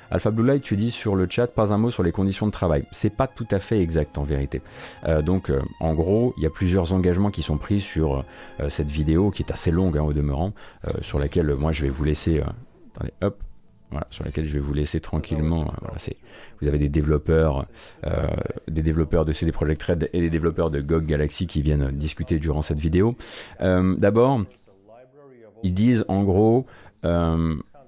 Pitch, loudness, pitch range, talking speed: 85 Hz, -23 LUFS, 75-100 Hz, 215 wpm